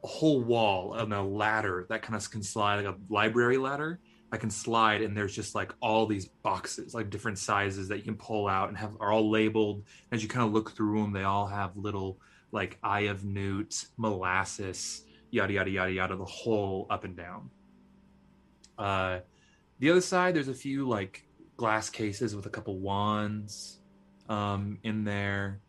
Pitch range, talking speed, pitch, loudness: 100-110 Hz, 185 wpm, 105 Hz, -31 LUFS